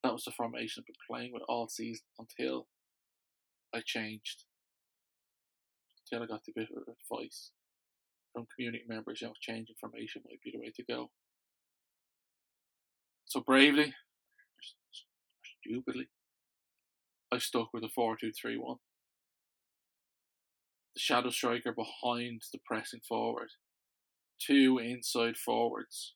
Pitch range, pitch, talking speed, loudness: 110-120 Hz, 115 Hz, 120 wpm, -35 LUFS